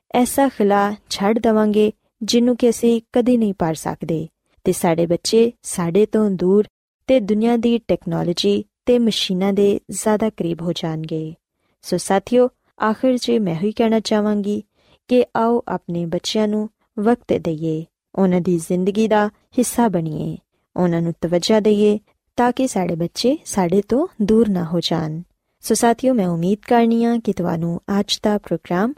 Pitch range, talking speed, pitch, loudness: 180-230 Hz, 150 wpm, 210 Hz, -19 LUFS